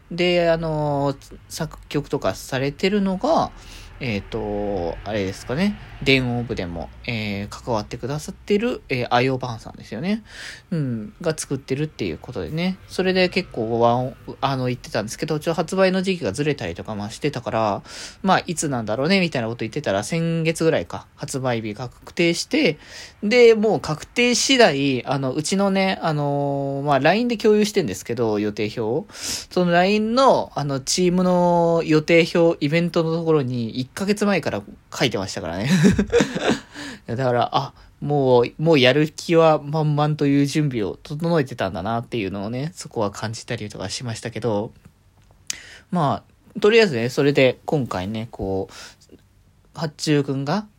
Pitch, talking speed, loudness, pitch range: 145 Hz, 320 characters per minute, -21 LUFS, 115-175 Hz